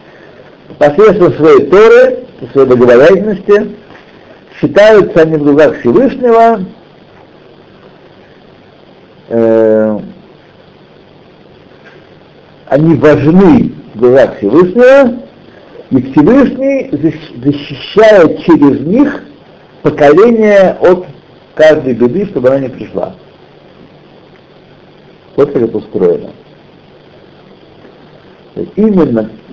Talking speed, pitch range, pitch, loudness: 70 wpm, 140-220 Hz, 175 Hz, -8 LUFS